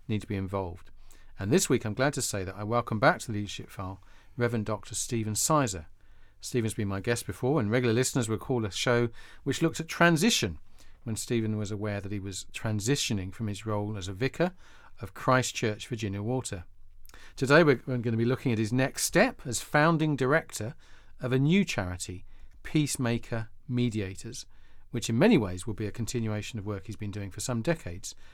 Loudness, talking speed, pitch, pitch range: -29 LUFS, 200 wpm, 110 Hz, 100-130 Hz